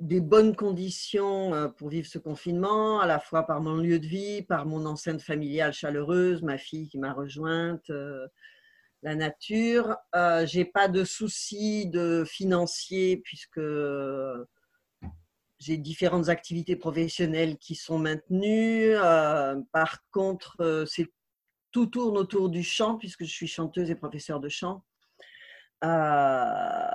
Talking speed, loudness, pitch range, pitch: 140 wpm, -28 LUFS, 155-195 Hz, 170 Hz